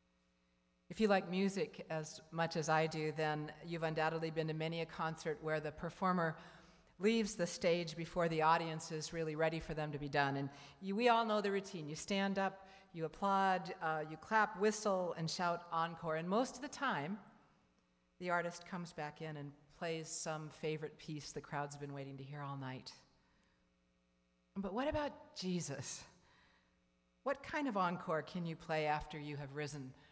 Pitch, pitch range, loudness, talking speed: 160 Hz, 150-185 Hz, -39 LUFS, 180 wpm